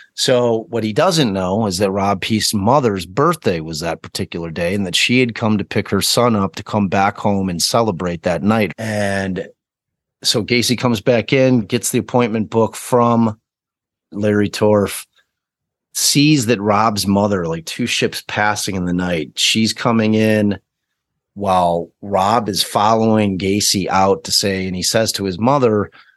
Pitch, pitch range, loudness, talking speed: 105 Hz, 95-115 Hz, -16 LUFS, 170 wpm